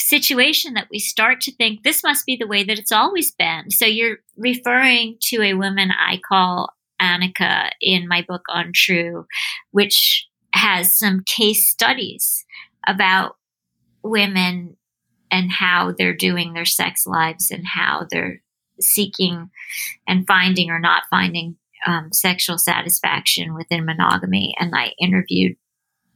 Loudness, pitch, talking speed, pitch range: -17 LUFS, 185 Hz, 140 wpm, 170-215 Hz